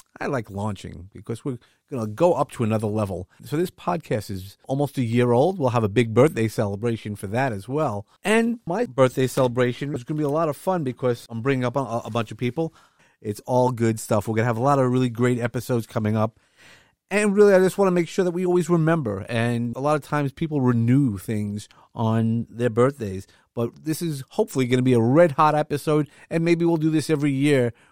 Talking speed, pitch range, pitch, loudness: 230 wpm, 115-155 Hz, 125 Hz, -23 LUFS